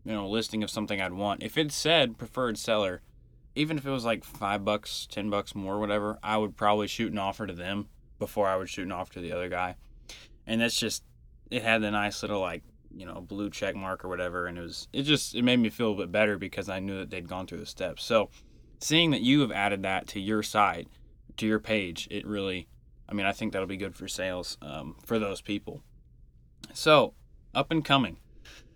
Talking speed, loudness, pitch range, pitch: 230 wpm, -29 LUFS, 90-110 Hz, 100 Hz